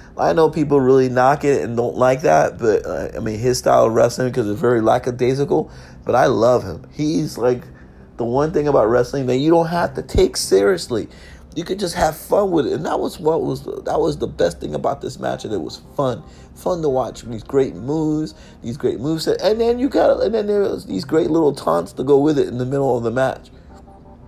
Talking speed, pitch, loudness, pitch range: 235 wpm, 125 Hz, -18 LUFS, 110-150 Hz